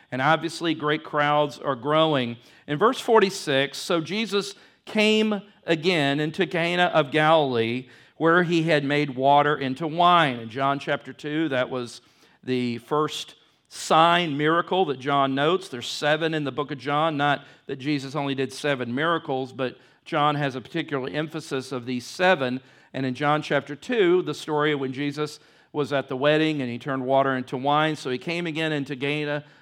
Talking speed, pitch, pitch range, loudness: 175 wpm, 150 Hz, 135-160 Hz, -24 LUFS